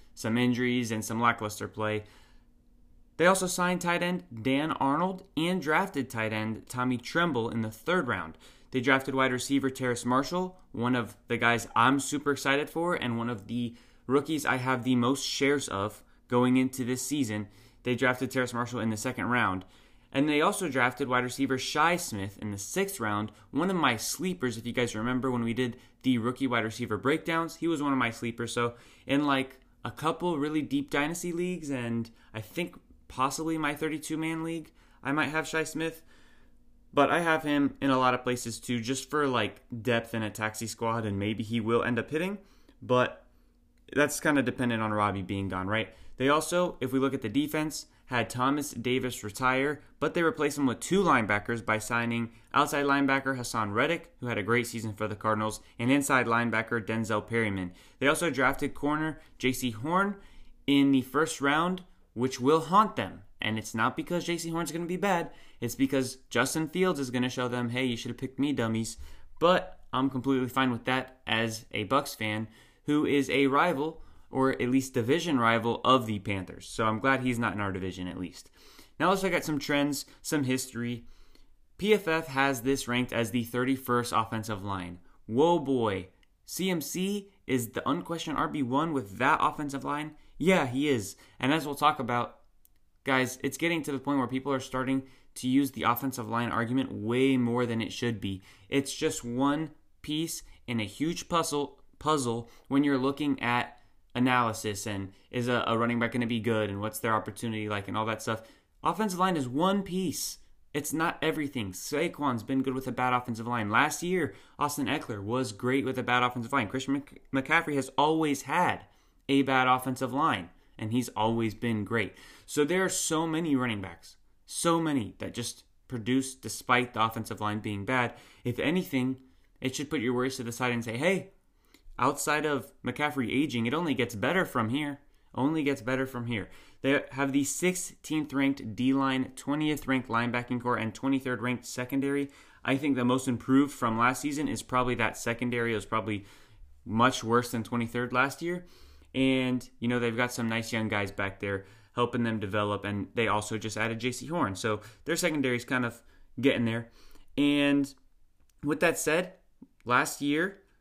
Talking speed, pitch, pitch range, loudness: 190 wpm, 125 Hz, 115-145 Hz, -29 LUFS